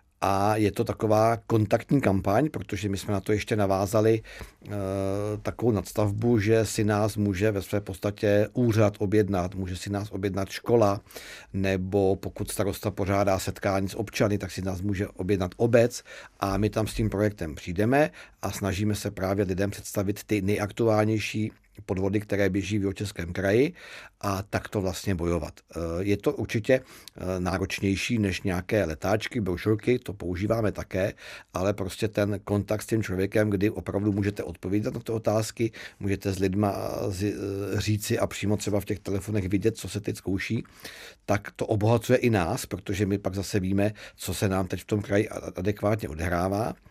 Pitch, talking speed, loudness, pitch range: 100 Hz, 165 wpm, -27 LUFS, 95-110 Hz